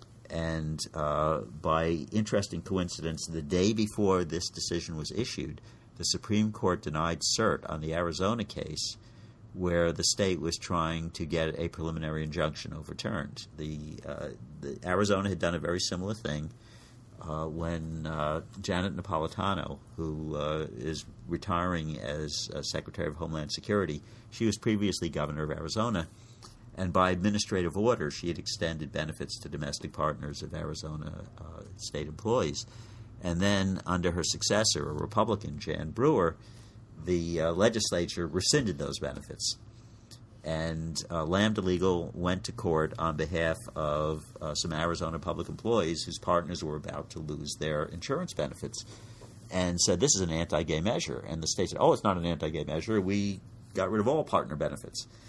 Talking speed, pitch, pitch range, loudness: 155 wpm, 85 Hz, 80-105 Hz, -31 LUFS